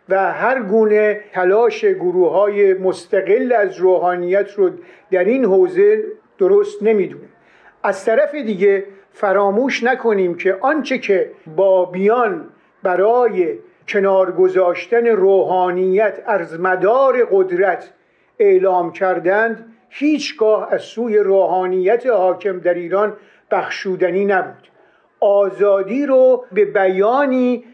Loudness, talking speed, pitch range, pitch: -16 LUFS, 95 wpm, 190-265 Hz, 210 Hz